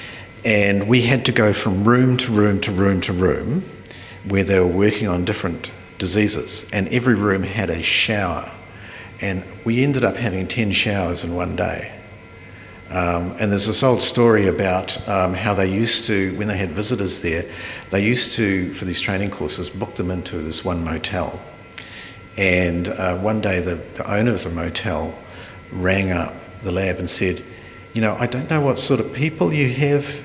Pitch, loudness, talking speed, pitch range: 100 Hz, -19 LUFS, 185 wpm, 90-115 Hz